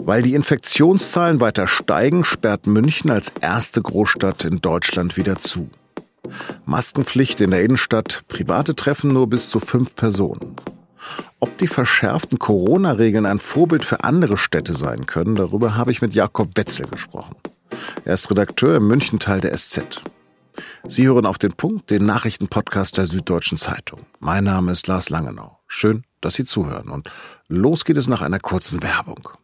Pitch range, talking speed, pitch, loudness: 100-130 Hz, 155 wpm, 110 Hz, -18 LUFS